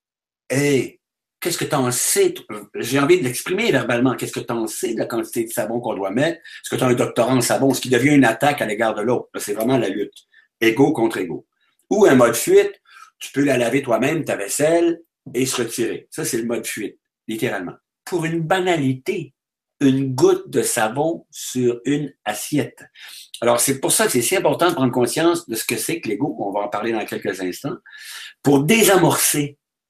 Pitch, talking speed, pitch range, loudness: 135 Hz, 210 wpm, 125-170 Hz, -19 LUFS